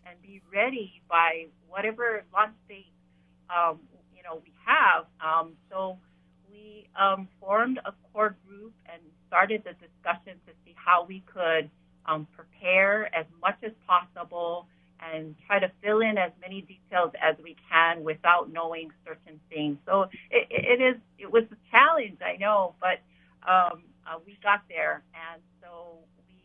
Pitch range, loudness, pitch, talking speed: 165-200 Hz, -26 LUFS, 180 Hz, 155 wpm